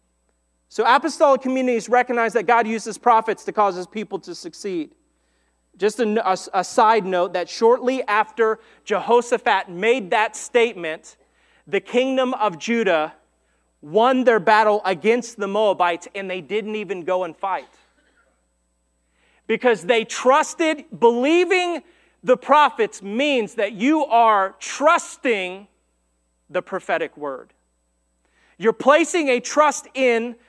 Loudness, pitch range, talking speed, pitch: -20 LUFS, 180-255 Hz, 125 wpm, 220 Hz